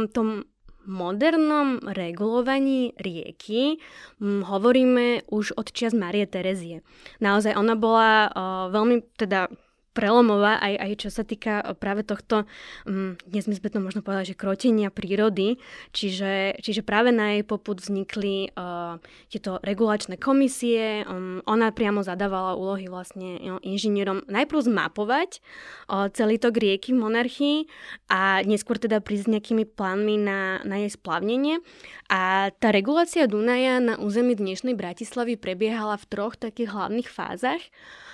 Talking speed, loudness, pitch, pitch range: 135 wpm, -24 LUFS, 210 Hz, 195-235 Hz